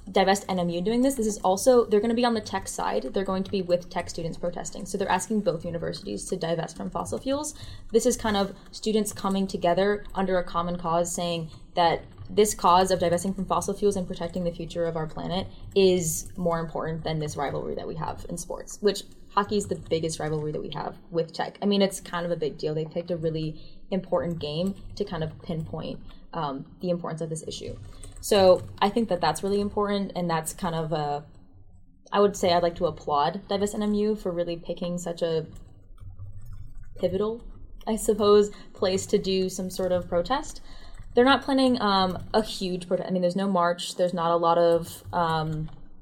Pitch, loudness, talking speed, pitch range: 180 Hz, -26 LUFS, 205 wpm, 165-200 Hz